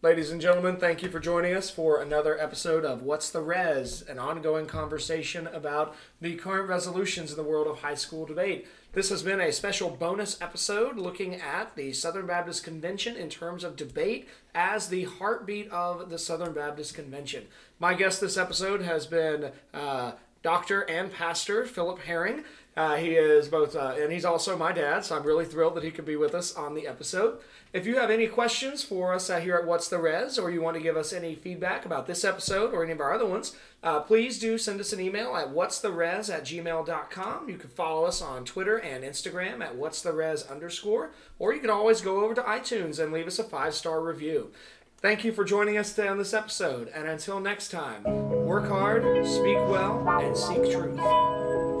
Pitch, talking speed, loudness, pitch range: 175 Hz, 210 wpm, -29 LUFS, 155-200 Hz